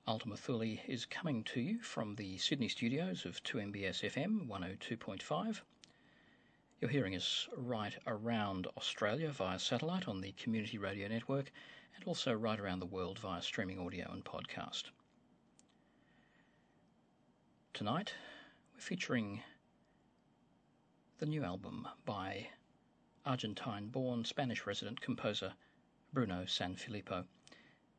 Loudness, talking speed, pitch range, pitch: -41 LUFS, 110 wpm, 95-130 Hz, 110 Hz